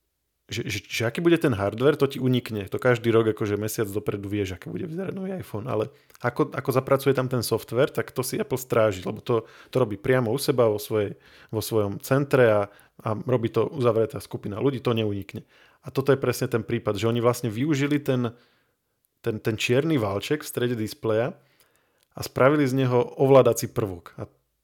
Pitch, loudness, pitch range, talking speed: 120 Hz, -25 LUFS, 110-135 Hz, 195 wpm